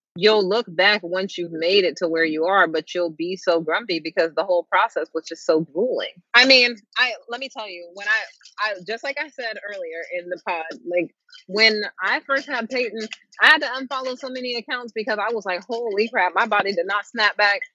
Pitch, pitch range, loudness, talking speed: 210 Hz, 180-250 Hz, -21 LUFS, 225 wpm